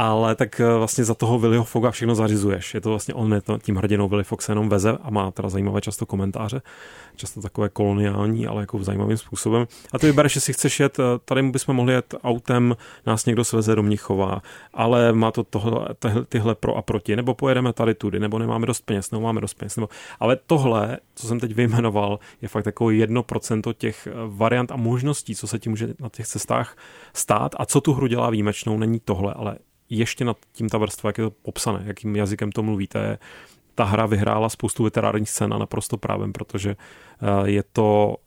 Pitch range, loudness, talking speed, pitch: 105-120 Hz, -22 LUFS, 200 wpm, 110 Hz